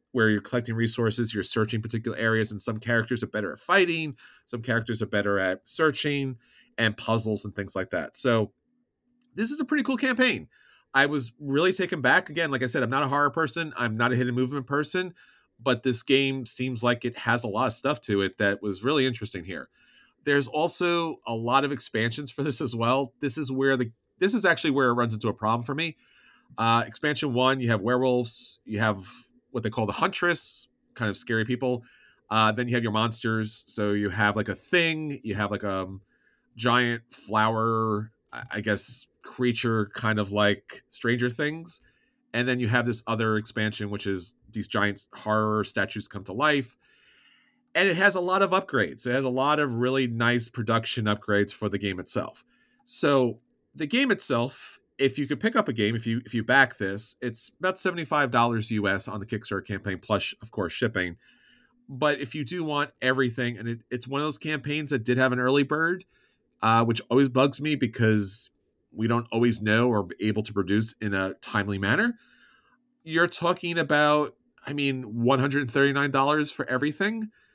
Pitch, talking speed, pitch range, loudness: 125 Hz, 195 wpm, 110-145 Hz, -26 LUFS